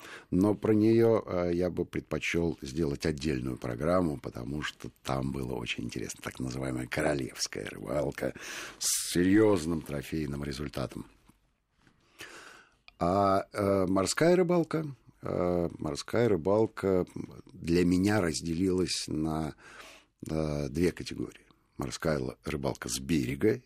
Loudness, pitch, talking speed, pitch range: -30 LUFS, 85 Hz, 95 wpm, 70-95 Hz